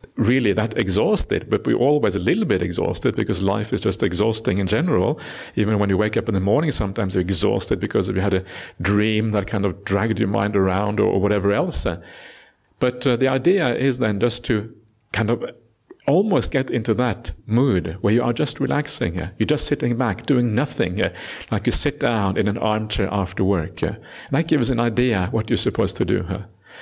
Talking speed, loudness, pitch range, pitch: 195 wpm, -21 LUFS, 100-120 Hz, 110 Hz